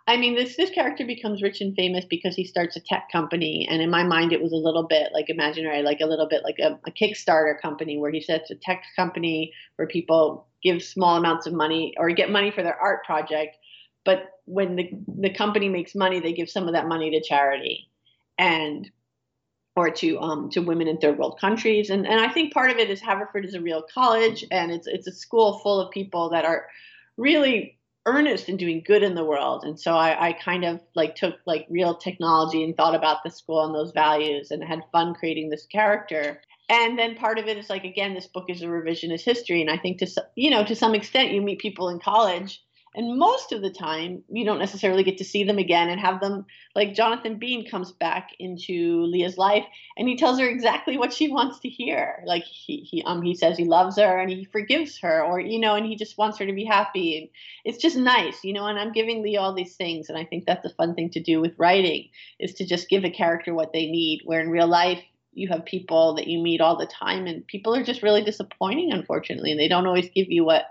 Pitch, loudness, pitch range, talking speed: 185 Hz, -23 LUFS, 165-210 Hz, 240 wpm